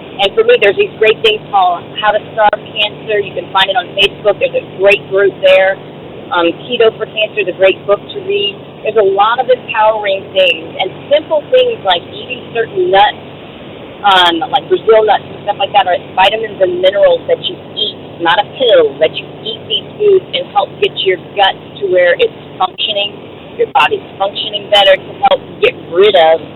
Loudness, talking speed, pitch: -11 LUFS, 195 wpm, 225 Hz